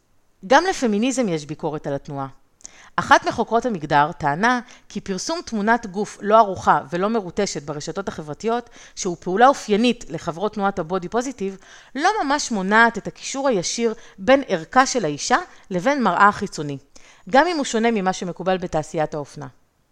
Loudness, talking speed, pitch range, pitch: -21 LUFS, 145 wpm, 165-240 Hz, 200 Hz